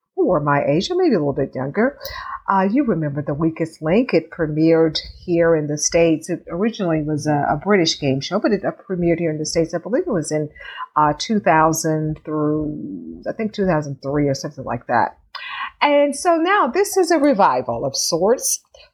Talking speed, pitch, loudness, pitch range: 195 wpm, 165 Hz, -19 LUFS, 150-215 Hz